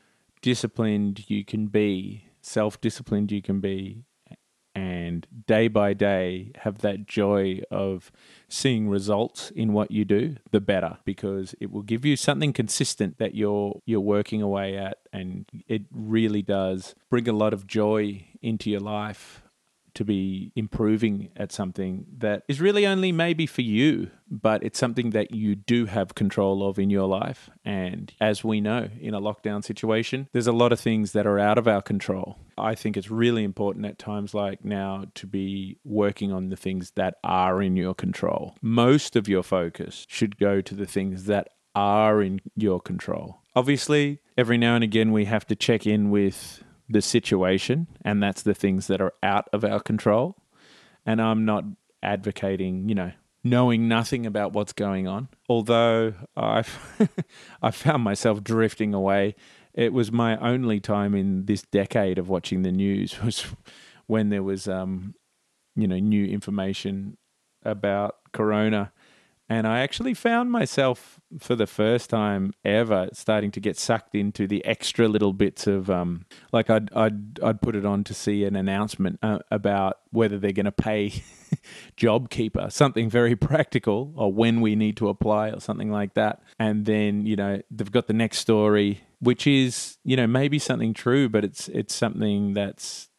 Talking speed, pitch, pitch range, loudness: 170 wpm, 105 Hz, 100-115 Hz, -25 LUFS